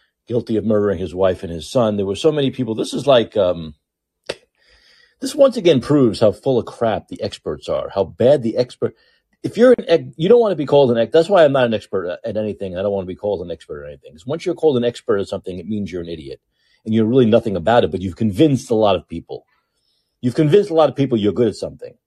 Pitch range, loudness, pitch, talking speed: 95-155 Hz, -17 LUFS, 115 Hz, 265 wpm